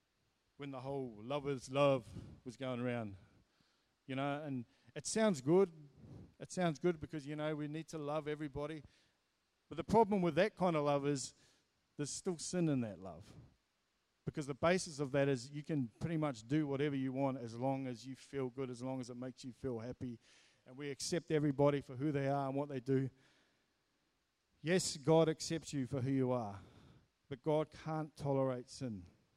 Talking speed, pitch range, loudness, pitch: 190 wpm, 130-155 Hz, -38 LUFS, 140 Hz